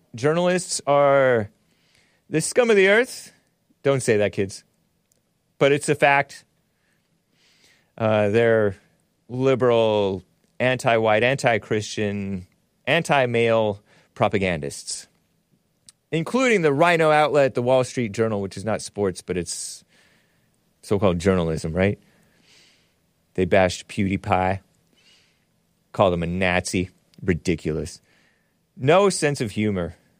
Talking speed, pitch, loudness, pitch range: 110 wpm, 110 Hz, -21 LUFS, 95-140 Hz